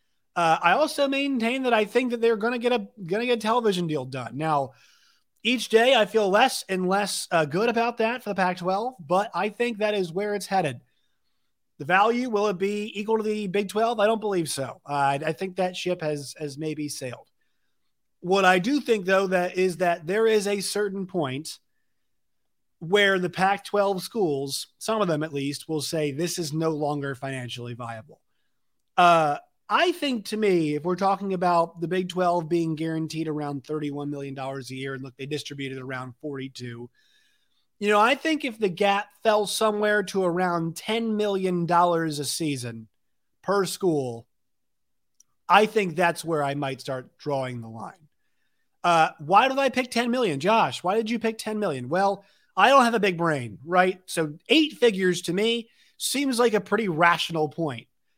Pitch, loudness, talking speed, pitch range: 185 Hz, -24 LUFS, 190 wpm, 150-215 Hz